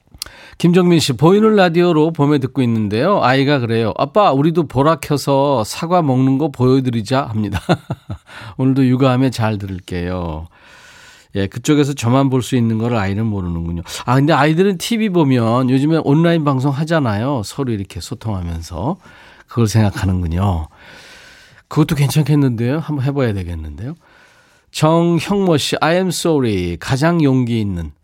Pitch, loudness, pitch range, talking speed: 135 Hz, -16 LUFS, 110-155 Hz, 335 characters per minute